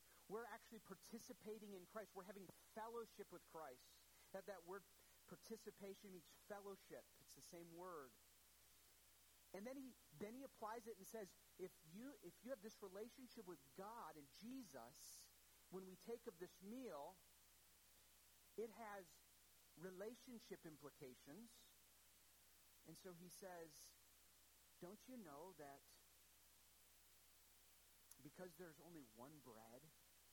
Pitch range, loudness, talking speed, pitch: 165-220 Hz, -60 LUFS, 125 wpm, 190 Hz